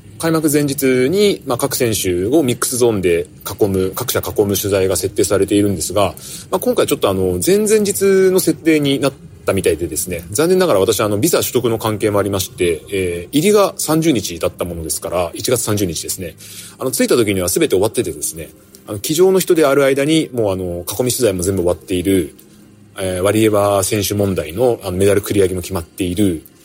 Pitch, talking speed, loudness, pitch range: 105 Hz, 390 characters per minute, -16 LUFS, 95-145 Hz